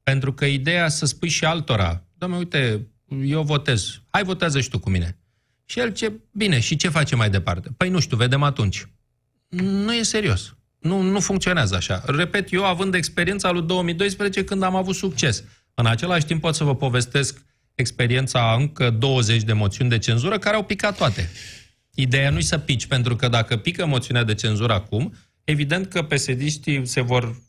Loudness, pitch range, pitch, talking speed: -21 LUFS, 120-175 Hz, 135 Hz, 185 wpm